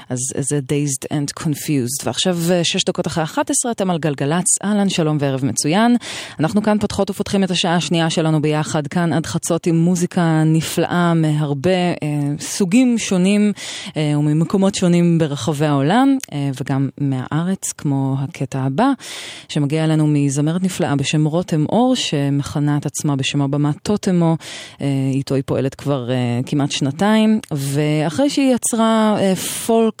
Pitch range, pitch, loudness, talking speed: 145-190 Hz, 160 Hz, -18 LUFS, 145 wpm